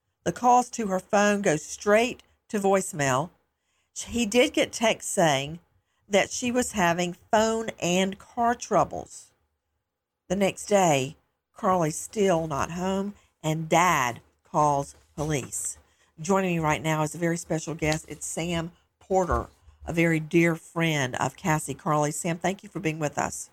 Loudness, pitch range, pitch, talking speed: -26 LUFS, 150-195 Hz, 170 Hz, 150 wpm